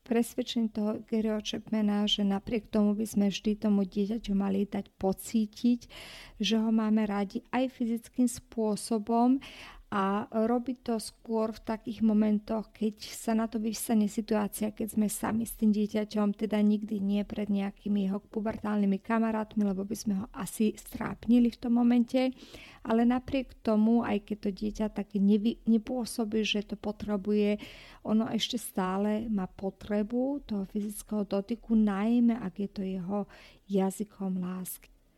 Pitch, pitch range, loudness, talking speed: 215 Hz, 205-230 Hz, -30 LUFS, 145 wpm